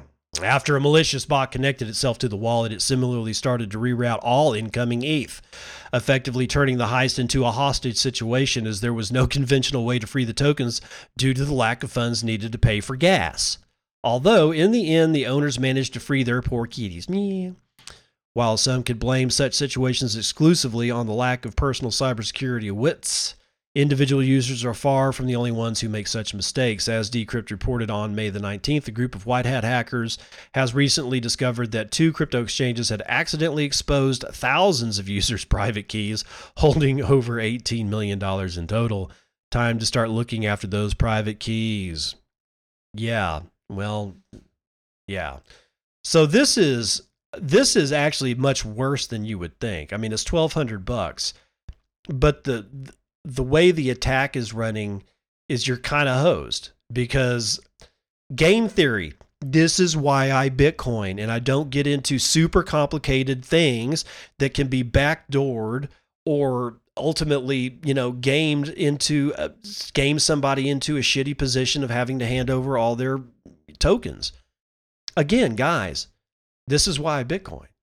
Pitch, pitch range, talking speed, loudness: 125 Hz, 115-140 Hz, 160 wpm, -22 LUFS